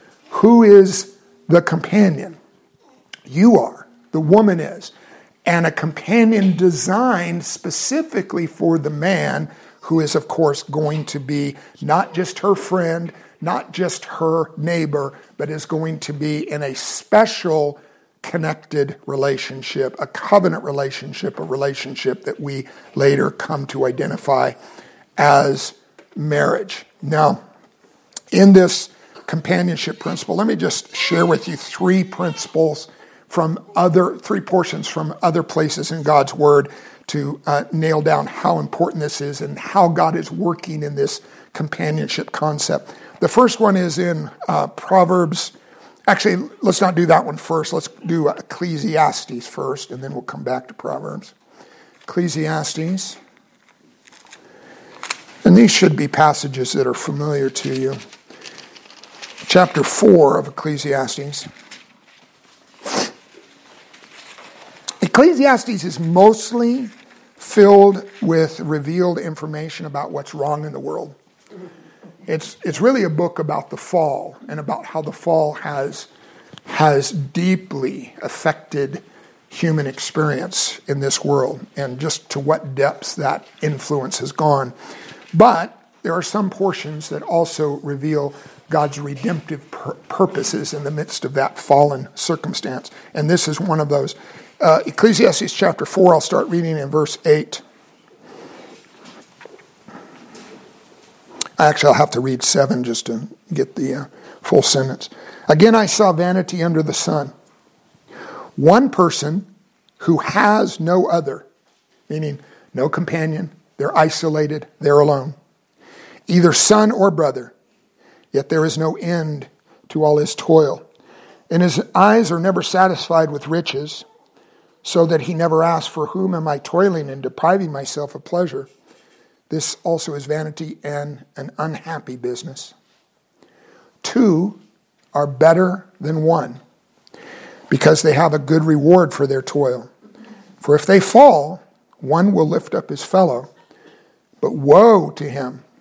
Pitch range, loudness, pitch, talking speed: 150-185 Hz, -17 LUFS, 160 Hz, 130 wpm